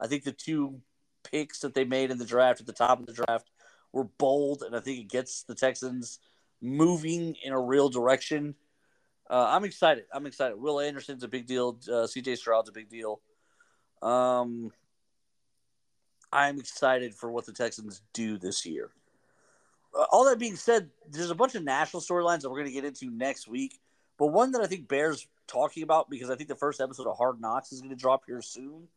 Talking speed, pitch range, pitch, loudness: 205 wpm, 125-155 Hz, 135 Hz, -29 LUFS